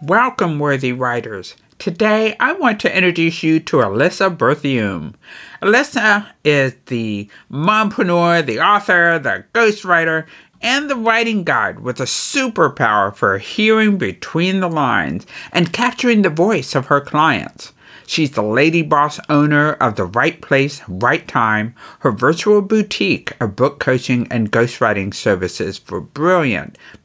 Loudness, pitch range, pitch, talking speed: -16 LUFS, 135-210 Hz, 165 Hz, 135 wpm